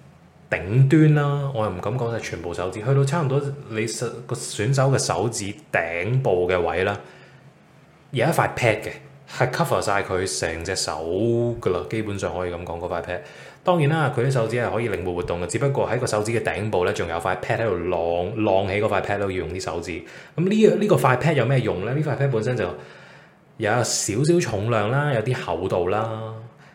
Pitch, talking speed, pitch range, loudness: 115 Hz, 330 characters per minute, 105-140 Hz, -23 LUFS